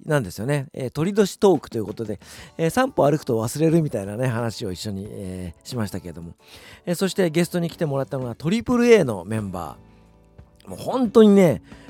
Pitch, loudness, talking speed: 125 Hz, -21 LUFS, 405 characters per minute